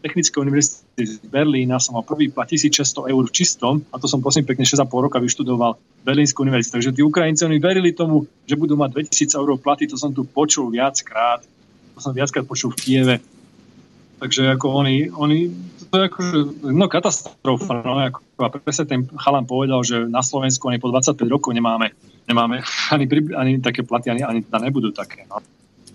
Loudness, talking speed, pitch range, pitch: -19 LUFS, 185 wpm, 125-150 Hz, 140 Hz